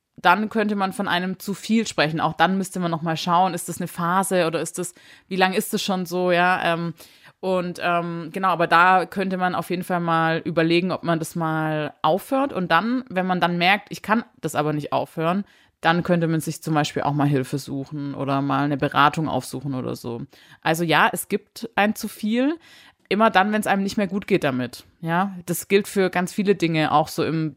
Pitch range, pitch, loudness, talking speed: 160-195 Hz, 175 Hz, -22 LUFS, 220 wpm